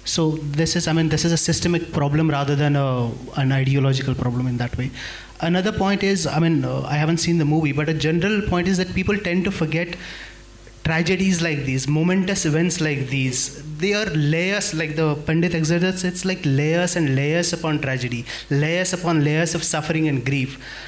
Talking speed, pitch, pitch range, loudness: 195 wpm, 160 Hz, 140-175 Hz, -21 LUFS